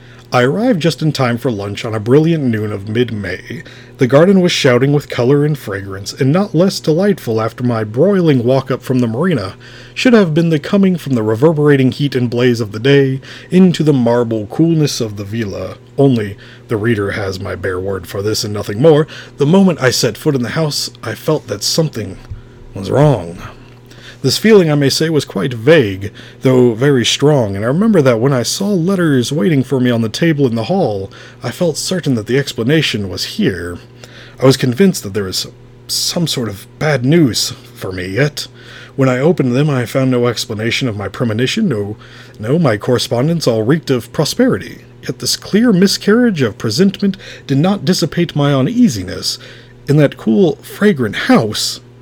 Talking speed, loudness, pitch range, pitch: 190 wpm, -14 LUFS, 120-150 Hz, 130 Hz